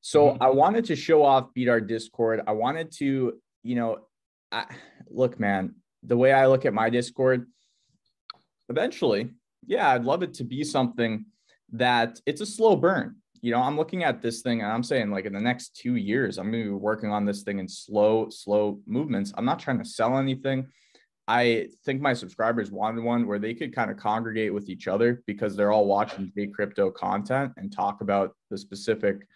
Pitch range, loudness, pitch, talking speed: 105-130 Hz, -26 LUFS, 120 Hz, 200 wpm